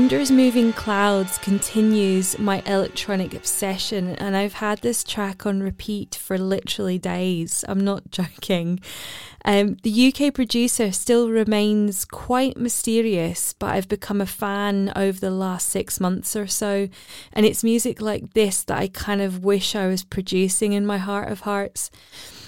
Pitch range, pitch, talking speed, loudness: 190-215 Hz, 200 Hz, 155 wpm, -22 LUFS